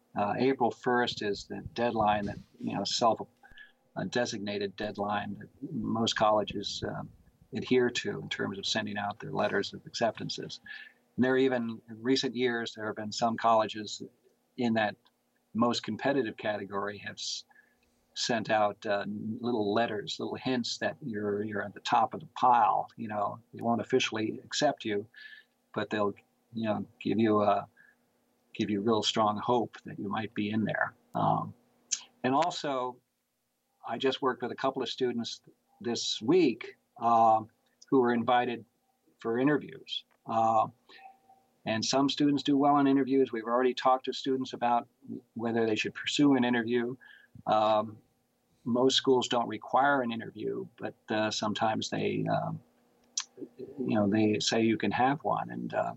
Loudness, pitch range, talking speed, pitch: -30 LUFS, 105-125 Hz, 160 wpm, 115 Hz